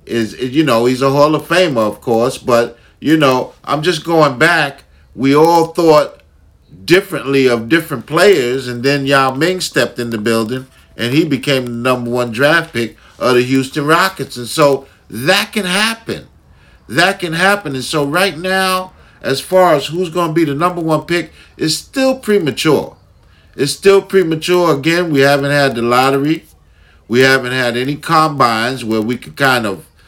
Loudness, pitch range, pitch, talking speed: -13 LUFS, 125-165 Hz, 140 Hz, 180 wpm